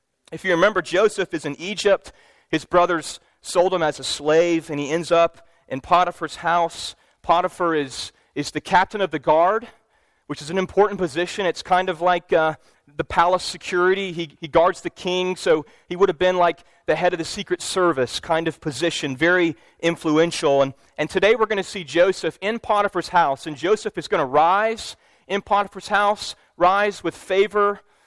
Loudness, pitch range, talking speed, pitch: -21 LUFS, 160-190 Hz, 185 wpm, 175 Hz